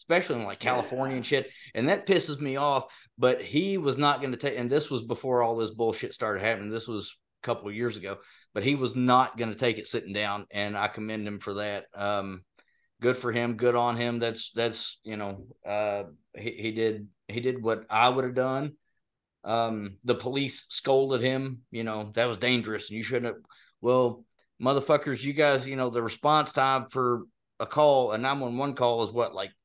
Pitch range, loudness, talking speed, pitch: 110-130 Hz, -28 LUFS, 215 wpm, 120 Hz